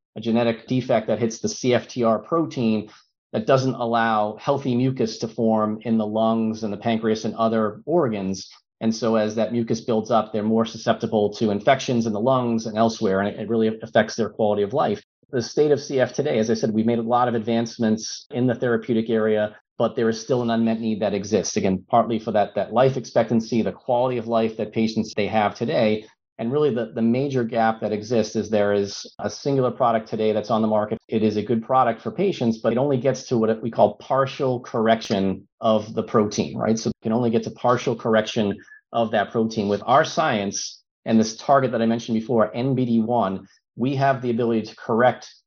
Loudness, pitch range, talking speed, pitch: -22 LUFS, 110-120 Hz, 210 wpm, 115 Hz